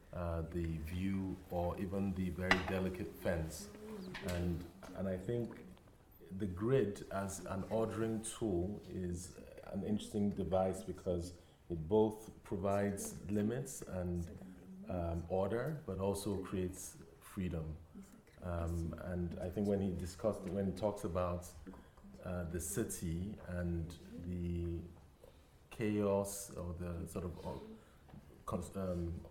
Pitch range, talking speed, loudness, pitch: 85-100 Hz, 115 wpm, -40 LUFS, 95 Hz